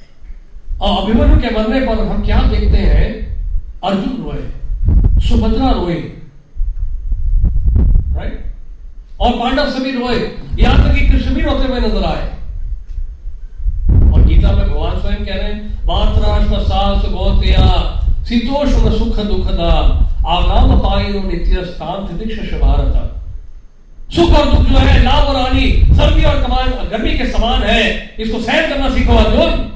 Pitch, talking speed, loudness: 90 Hz, 130 wpm, -15 LUFS